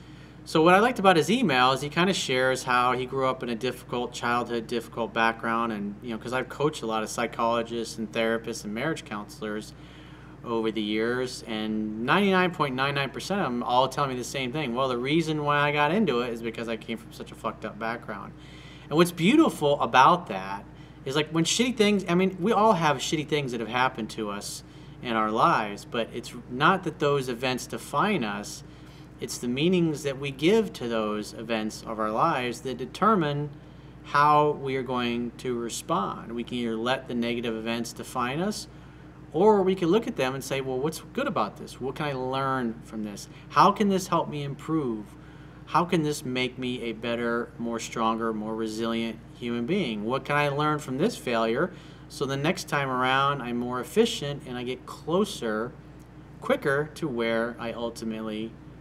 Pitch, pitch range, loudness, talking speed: 130 Hz, 115-150 Hz, -26 LUFS, 195 wpm